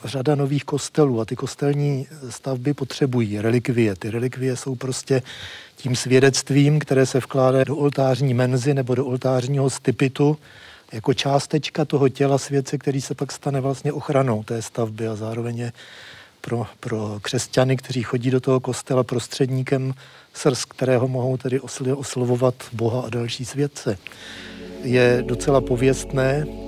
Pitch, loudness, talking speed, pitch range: 130 Hz, -22 LUFS, 135 wpm, 125-140 Hz